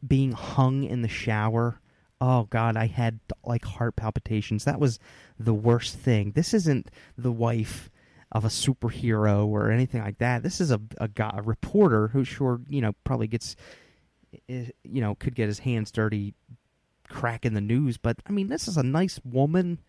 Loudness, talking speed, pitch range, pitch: -26 LUFS, 180 wpm, 110-135 Hz, 120 Hz